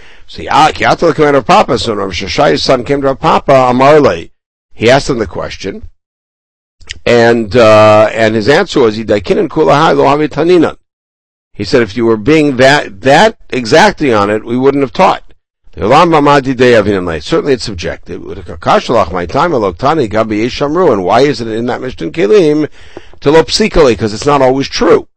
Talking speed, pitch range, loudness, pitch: 125 wpm, 105-145 Hz, -9 LUFS, 120 Hz